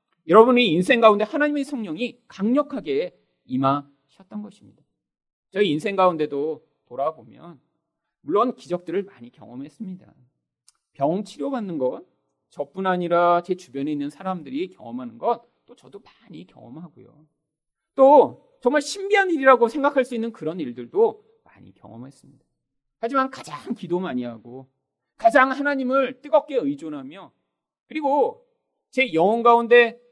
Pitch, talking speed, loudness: 215 Hz, 305 characters per minute, -21 LUFS